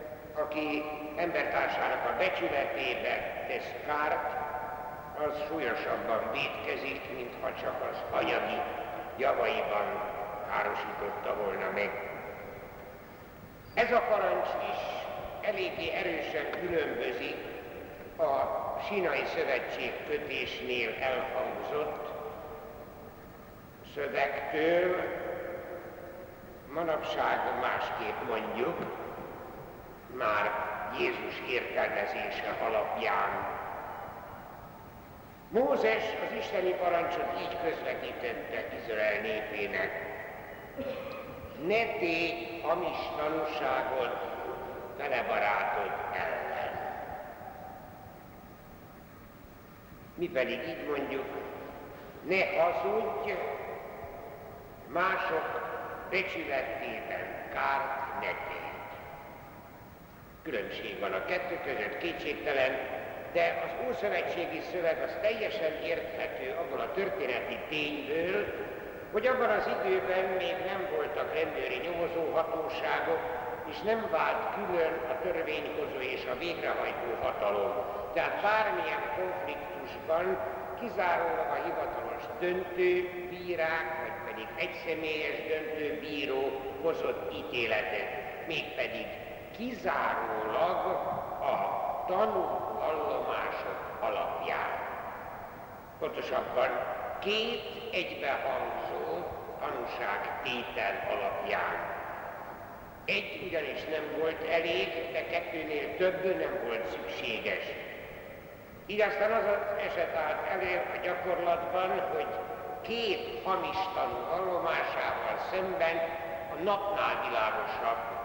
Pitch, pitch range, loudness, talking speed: 165 Hz, 150-190 Hz, -33 LUFS, 80 wpm